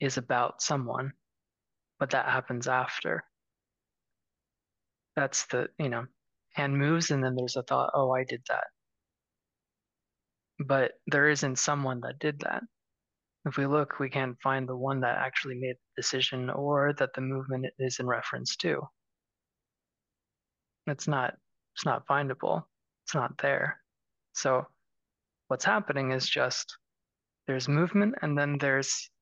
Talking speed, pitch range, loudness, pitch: 140 wpm, 130-145 Hz, -30 LUFS, 135 Hz